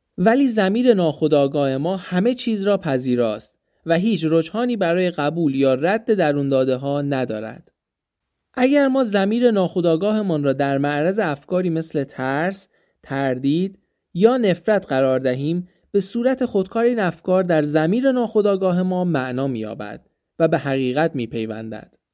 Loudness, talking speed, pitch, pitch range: -20 LUFS, 135 wpm, 170 Hz, 140-205 Hz